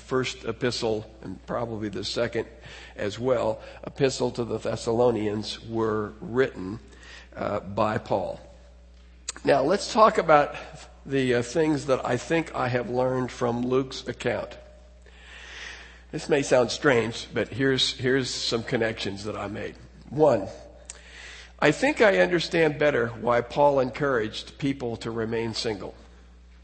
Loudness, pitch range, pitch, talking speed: -25 LUFS, 100-130 Hz, 115 Hz, 130 wpm